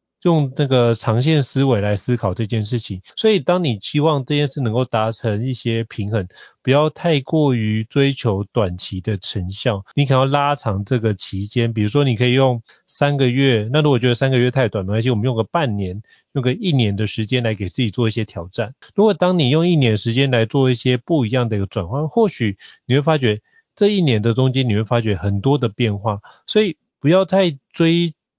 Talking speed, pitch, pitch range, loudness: 310 characters per minute, 125 Hz, 110-145 Hz, -18 LUFS